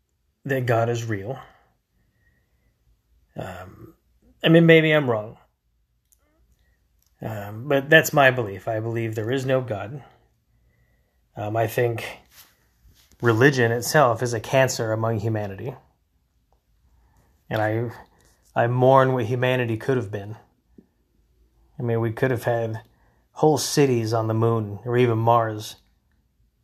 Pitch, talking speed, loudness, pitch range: 115 Hz, 125 wpm, -21 LUFS, 95-125 Hz